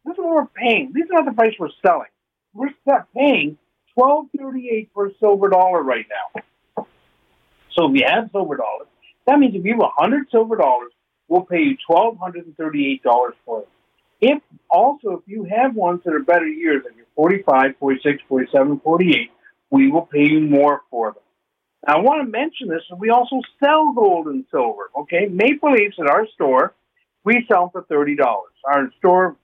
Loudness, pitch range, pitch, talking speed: -18 LUFS, 165-280 Hz, 225 Hz, 185 wpm